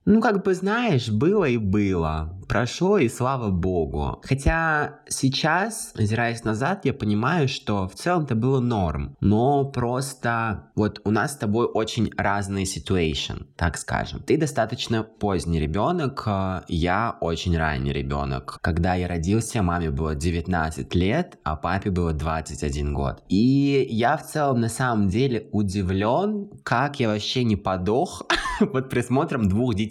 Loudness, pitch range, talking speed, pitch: -24 LUFS, 90-135 Hz, 145 wpm, 105 Hz